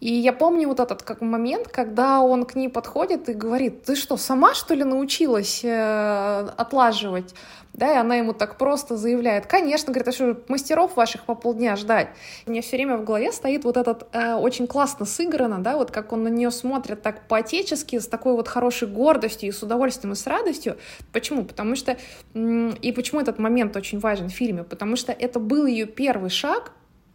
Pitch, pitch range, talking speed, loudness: 240 Hz, 225-260 Hz, 200 wpm, -23 LUFS